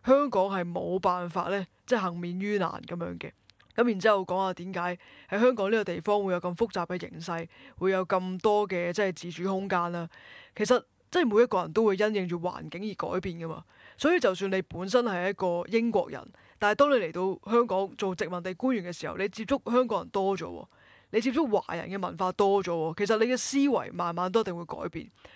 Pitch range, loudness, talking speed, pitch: 180-220 Hz, -29 LUFS, 315 characters per minute, 190 Hz